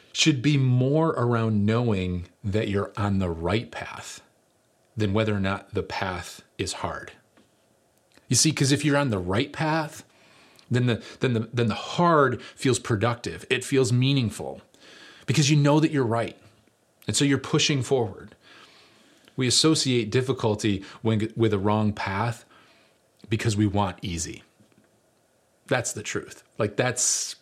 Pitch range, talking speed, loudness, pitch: 105-135 Hz, 150 wpm, -24 LUFS, 115 Hz